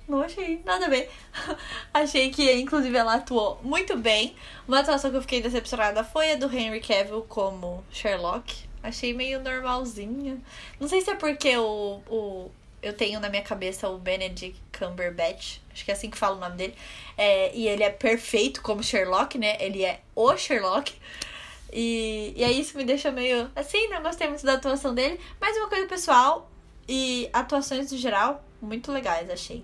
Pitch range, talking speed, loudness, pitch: 210-280 Hz, 180 wpm, -26 LUFS, 245 Hz